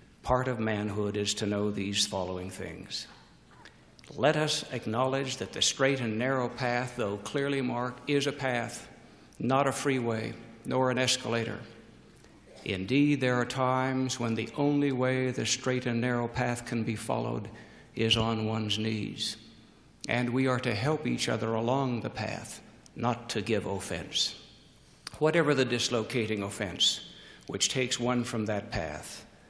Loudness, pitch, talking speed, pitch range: -30 LUFS, 120 Hz, 150 wpm, 110-130 Hz